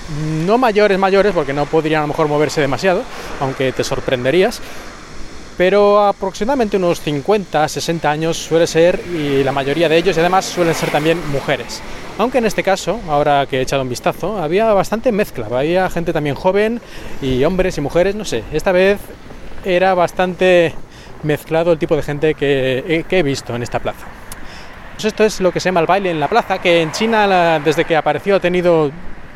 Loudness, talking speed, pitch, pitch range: -16 LUFS, 190 wpm, 165 Hz, 145-190 Hz